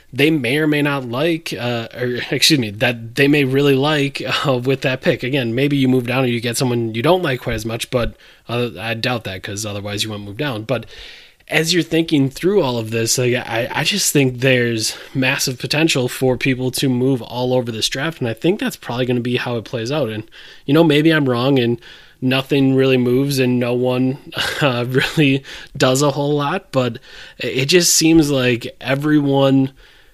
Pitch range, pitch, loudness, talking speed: 120-145 Hz, 130 Hz, -17 LUFS, 210 wpm